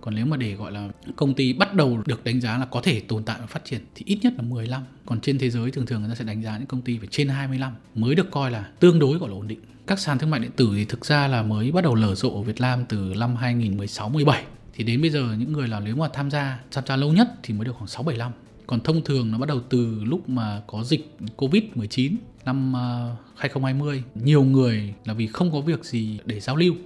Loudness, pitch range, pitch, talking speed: -24 LUFS, 115-140 Hz, 125 Hz, 270 wpm